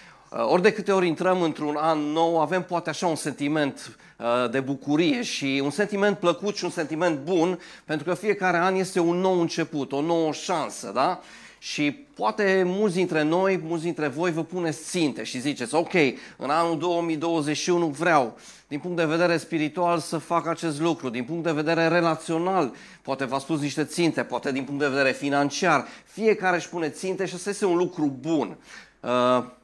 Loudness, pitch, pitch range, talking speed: -25 LUFS, 165 Hz, 150-180 Hz, 180 wpm